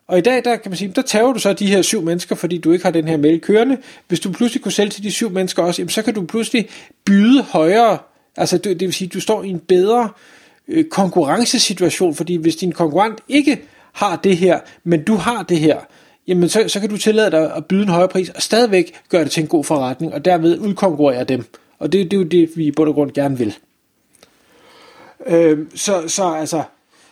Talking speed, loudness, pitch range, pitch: 230 wpm, -16 LUFS, 170-220 Hz, 185 Hz